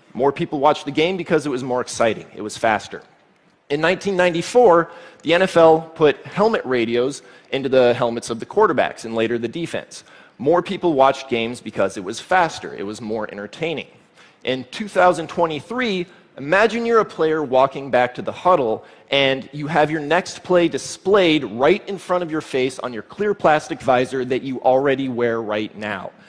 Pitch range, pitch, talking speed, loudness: 125-175 Hz, 150 Hz, 175 wpm, -19 LUFS